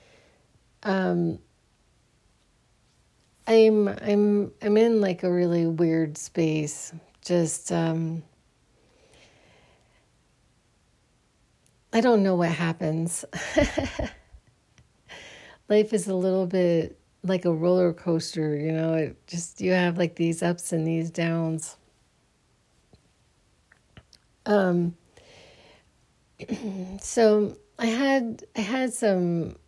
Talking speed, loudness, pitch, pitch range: 90 wpm, -25 LUFS, 180 Hz, 165-210 Hz